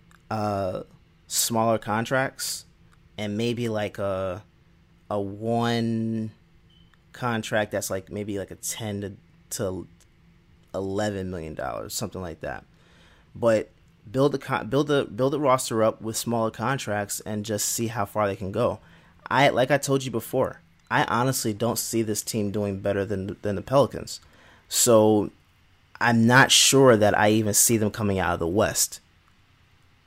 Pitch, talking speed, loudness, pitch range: 105 Hz, 155 wpm, -24 LUFS, 100-115 Hz